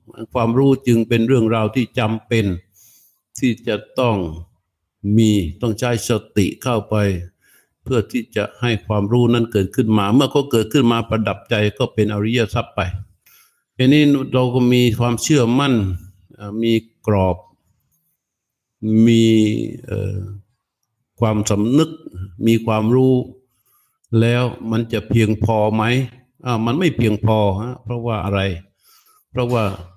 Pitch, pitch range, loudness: 115 Hz, 105-125 Hz, -18 LUFS